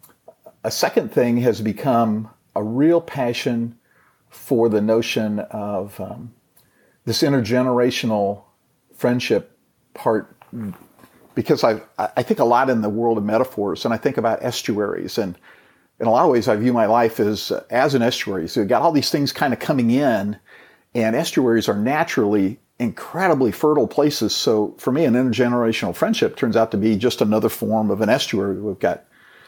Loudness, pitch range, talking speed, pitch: -20 LUFS, 105-125 Hz, 170 wpm, 115 Hz